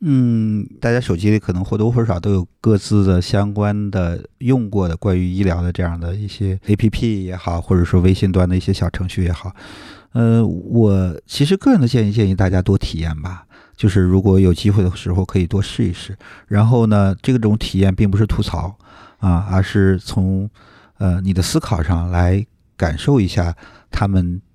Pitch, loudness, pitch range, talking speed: 95 Hz, -17 LUFS, 90-105 Hz, 280 characters per minute